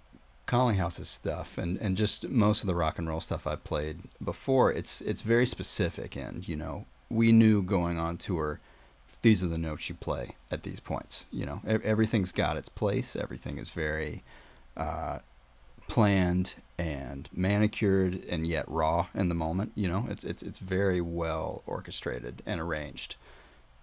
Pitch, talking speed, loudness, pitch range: 90 Hz, 165 wpm, -30 LUFS, 75-100 Hz